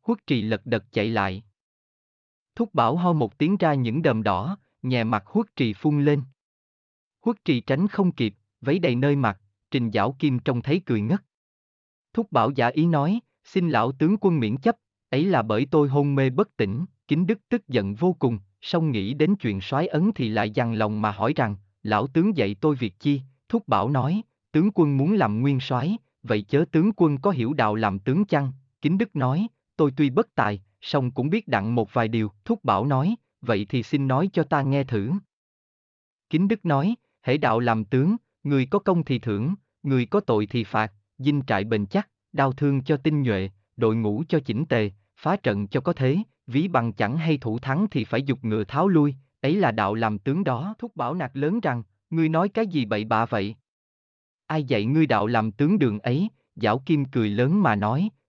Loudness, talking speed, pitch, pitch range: -24 LUFS, 210 wpm, 135 Hz, 110-165 Hz